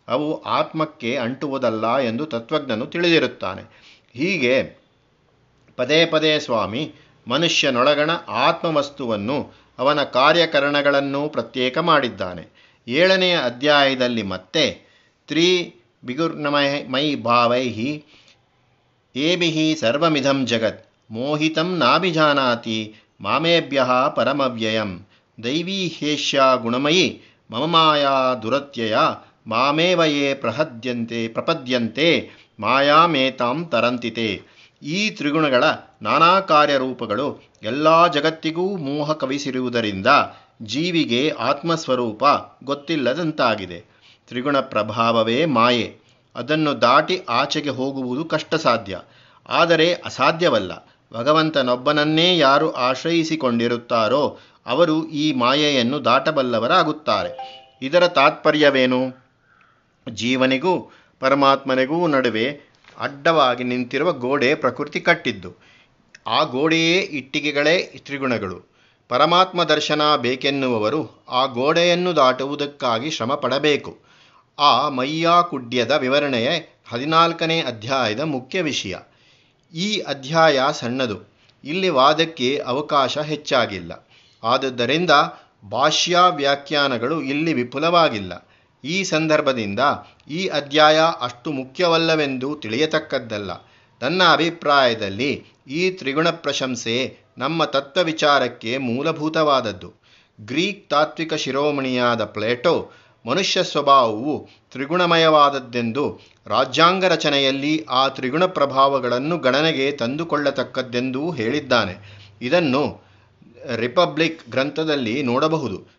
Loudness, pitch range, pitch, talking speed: -19 LUFS, 125-160 Hz, 140 Hz, 75 wpm